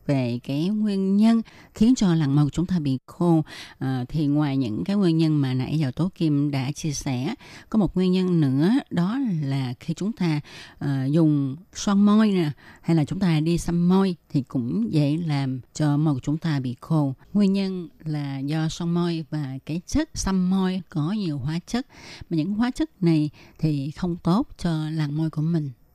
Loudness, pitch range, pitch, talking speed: -24 LUFS, 145-185 Hz, 160 Hz, 205 wpm